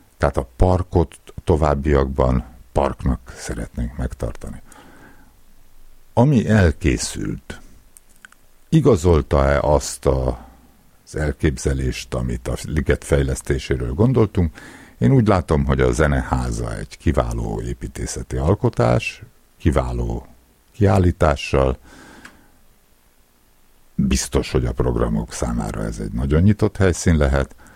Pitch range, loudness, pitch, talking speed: 60-90 Hz, -20 LUFS, 70 Hz, 90 wpm